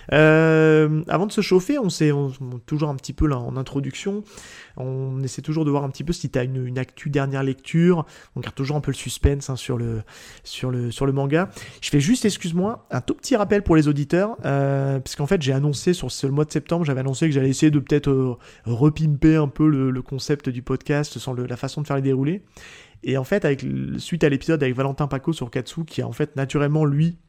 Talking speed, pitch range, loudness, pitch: 235 wpm, 130-155 Hz, -22 LUFS, 145 Hz